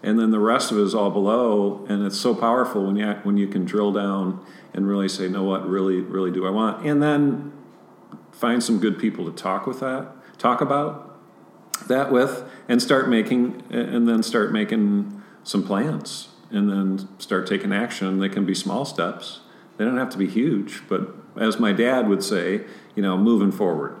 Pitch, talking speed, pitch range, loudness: 105 Hz, 200 wpm, 95-130 Hz, -22 LUFS